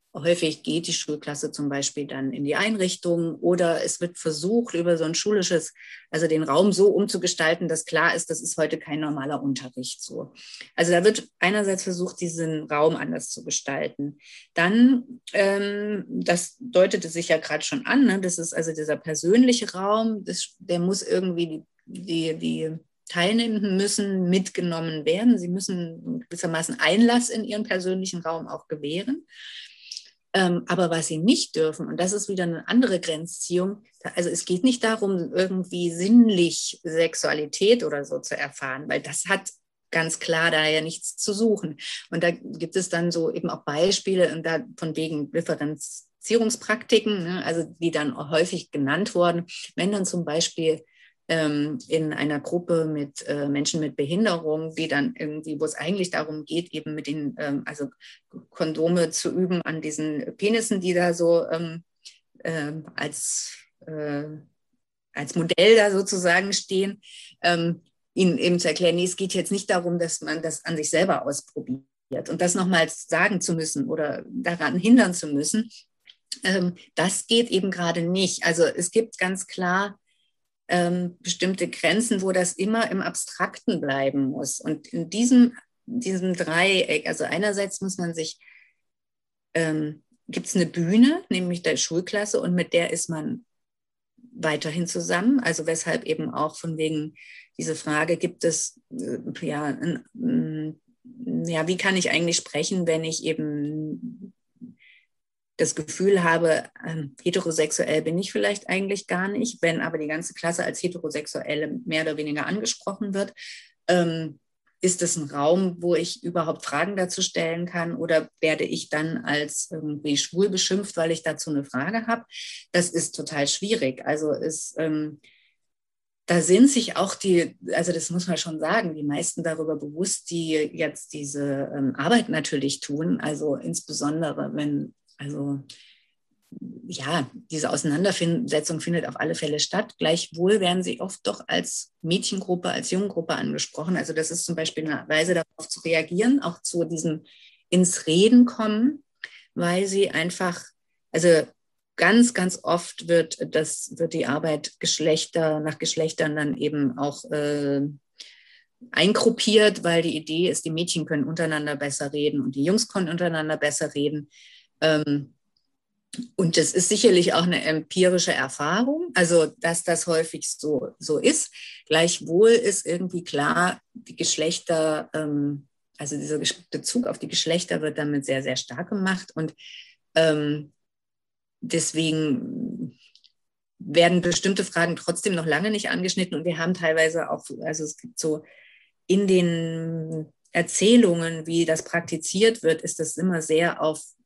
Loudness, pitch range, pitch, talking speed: -24 LUFS, 155-190 Hz, 170 Hz, 150 wpm